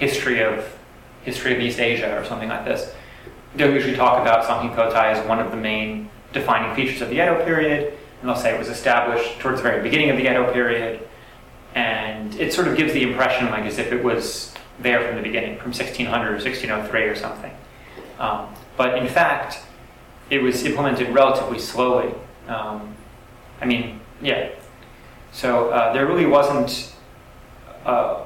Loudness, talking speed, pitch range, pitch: -21 LUFS, 170 wpm, 115-130 Hz, 120 Hz